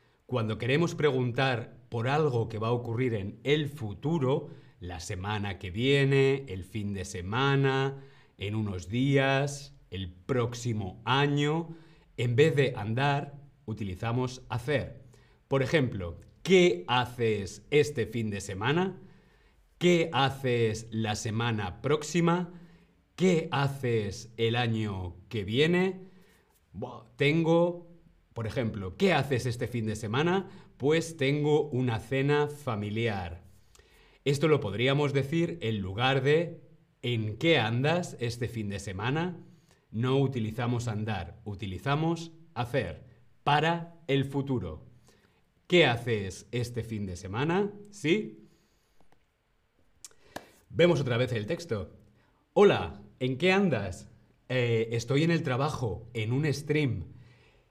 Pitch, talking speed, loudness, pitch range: 125 Hz, 115 wpm, -29 LUFS, 110-150 Hz